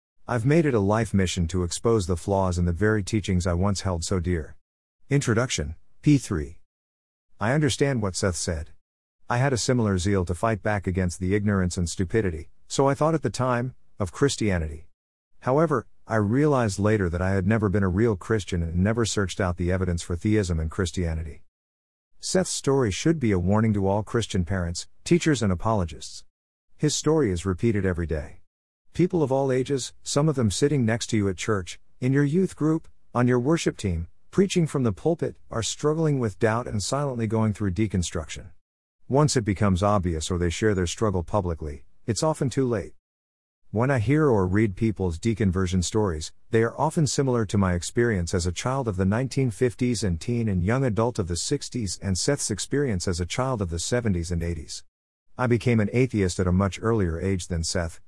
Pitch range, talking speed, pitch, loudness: 90-120 Hz, 195 wpm, 100 Hz, -25 LUFS